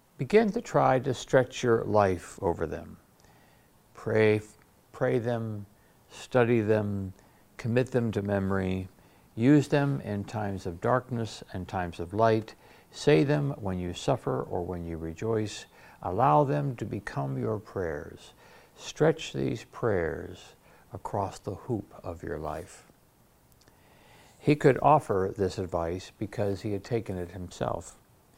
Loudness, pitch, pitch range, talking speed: -29 LUFS, 105 Hz, 95-125 Hz, 135 wpm